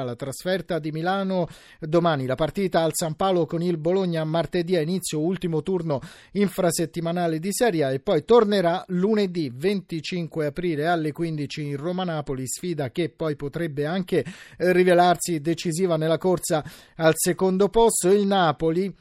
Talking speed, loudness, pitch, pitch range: 145 wpm, -24 LUFS, 170 Hz, 160-185 Hz